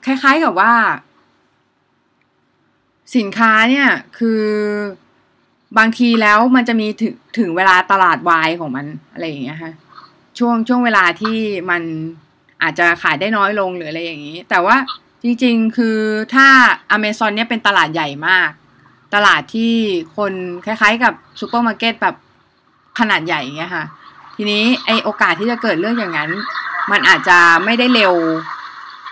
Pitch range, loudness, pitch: 175-235 Hz, -14 LUFS, 215 Hz